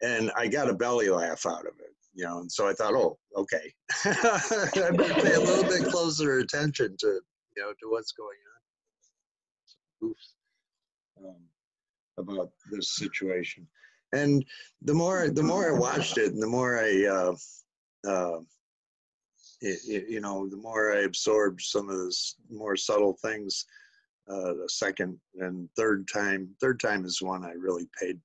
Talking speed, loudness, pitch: 170 wpm, -28 LUFS, 110 Hz